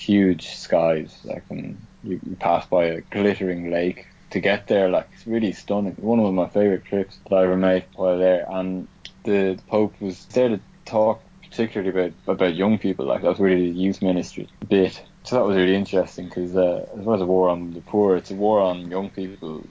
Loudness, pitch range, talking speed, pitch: -22 LUFS, 90-100 Hz, 215 wpm, 95 Hz